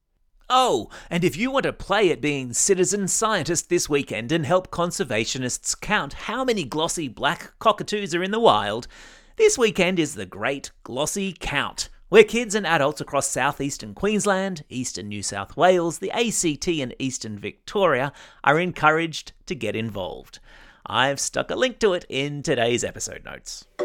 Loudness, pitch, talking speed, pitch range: -23 LUFS, 165 Hz, 160 wpm, 130-195 Hz